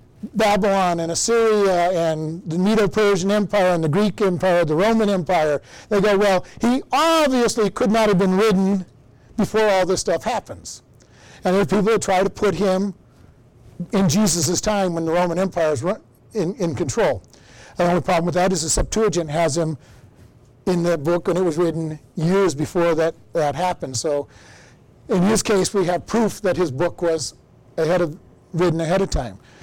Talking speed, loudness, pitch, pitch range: 180 wpm, -20 LUFS, 180 Hz, 165-200 Hz